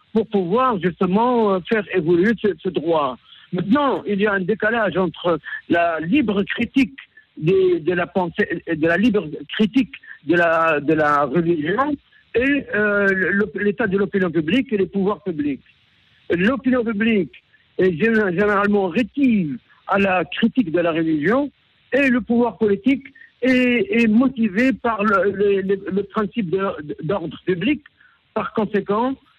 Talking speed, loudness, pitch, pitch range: 140 wpm, -19 LUFS, 205 Hz, 185-235 Hz